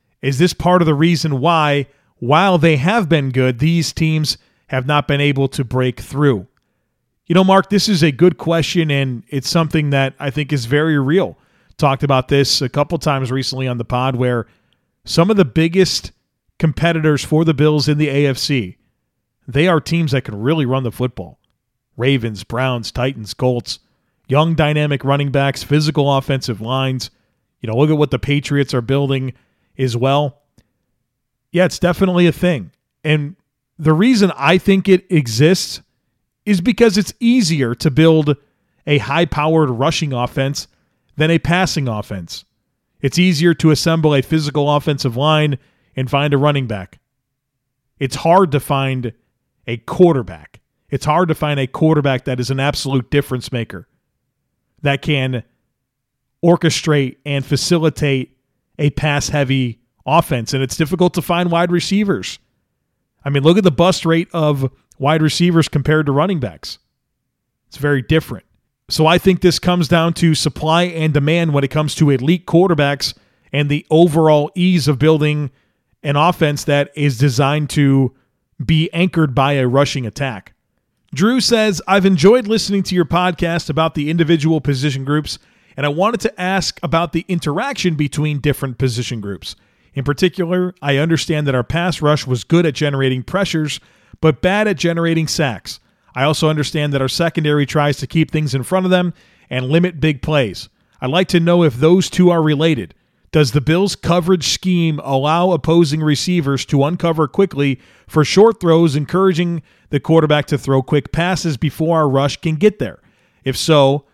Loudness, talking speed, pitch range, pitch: -16 LUFS, 165 wpm, 135-165 Hz, 150 Hz